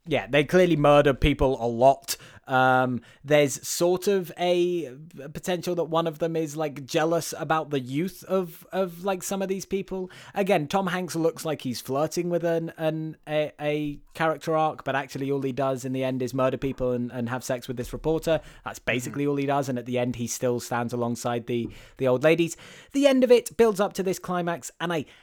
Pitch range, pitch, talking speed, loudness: 130-175 Hz, 155 Hz, 215 wpm, -26 LUFS